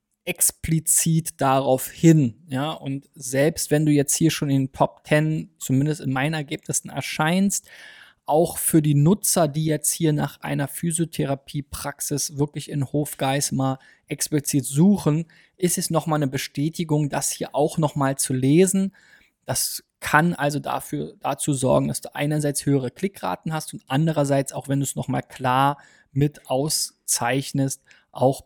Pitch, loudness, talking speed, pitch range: 145 Hz, -22 LUFS, 150 wpm, 135-155 Hz